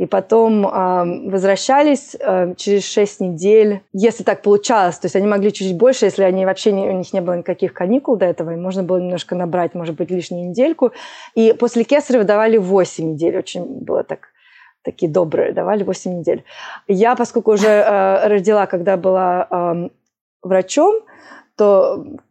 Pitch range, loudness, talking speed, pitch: 185-225 Hz, -16 LUFS, 165 wpm, 195 Hz